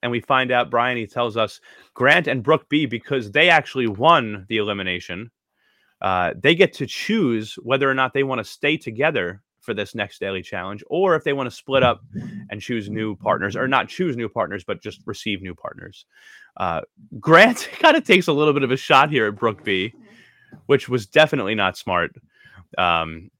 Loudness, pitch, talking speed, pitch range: -20 LUFS, 120 Hz, 200 wpm, 105-140 Hz